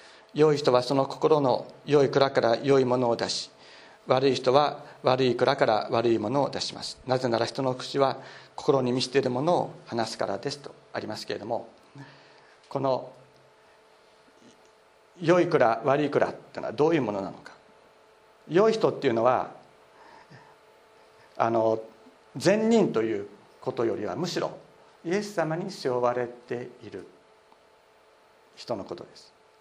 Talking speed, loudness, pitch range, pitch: 275 characters per minute, -26 LUFS, 120-155 Hz, 130 Hz